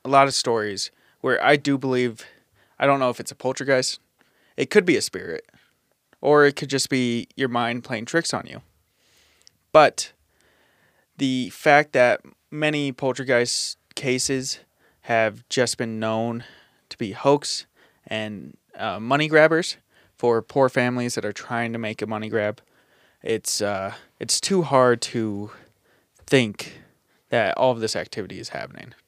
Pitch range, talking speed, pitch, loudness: 110-135 Hz, 150 wpm, 125 Hz, -22 LUFS